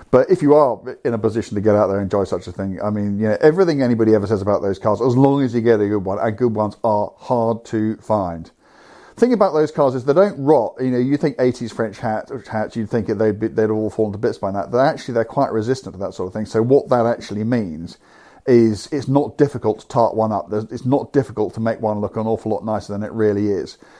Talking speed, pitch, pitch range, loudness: 270 wpm, 110 Hz, 105-130 Hz, -19 LUFS